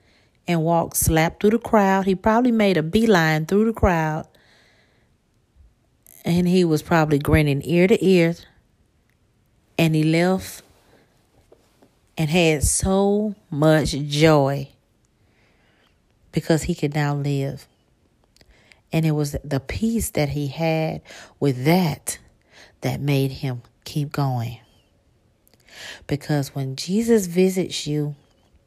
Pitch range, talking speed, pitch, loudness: 140-175 Hz, 115 wpm, 155 Hz, -21 LUFS